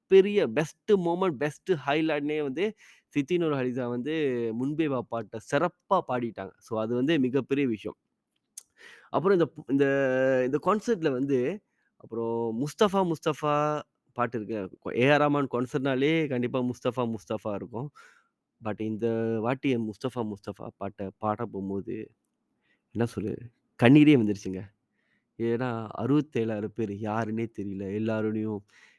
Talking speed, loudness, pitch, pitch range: 110 wpm, -28 LUFS, 125 Hz, 110-145 Hz